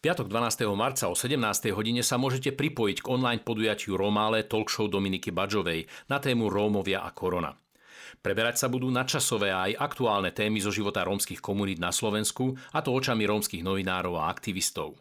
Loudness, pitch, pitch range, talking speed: -28 LUFS, 105 Hz, 100-125 Hz, 165 wpm